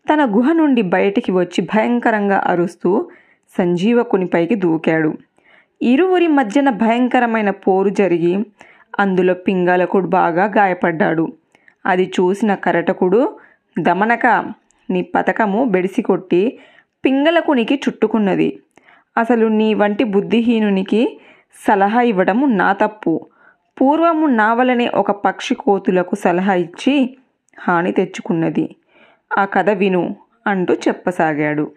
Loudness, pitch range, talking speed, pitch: -16 LUFS, 185-245 Hz, 95 wpm, 205 Hz